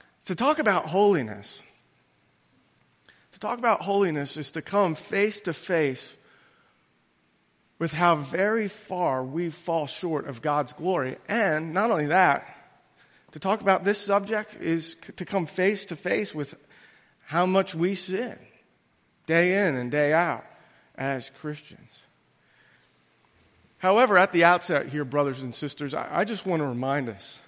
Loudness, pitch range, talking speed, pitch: -25 LUFS, 150-200 Hz, 140 wpm, 170 Hz